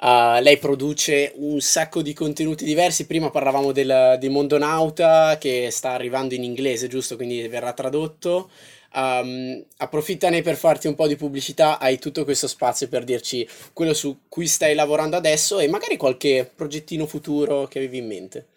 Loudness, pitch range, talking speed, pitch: -21 LUFS, 130-155 Hz, 160 wpm, 145 Hz